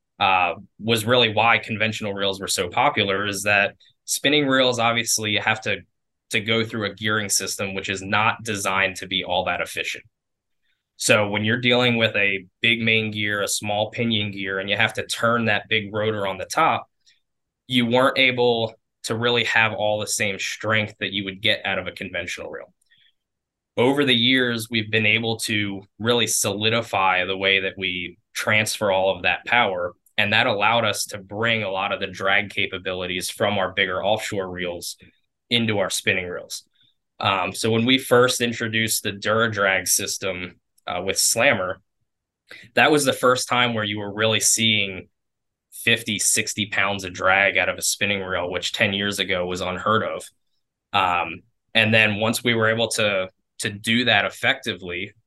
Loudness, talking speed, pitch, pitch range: -21 LUFS, 180 wpm, 110 Hz, 95-115 Hz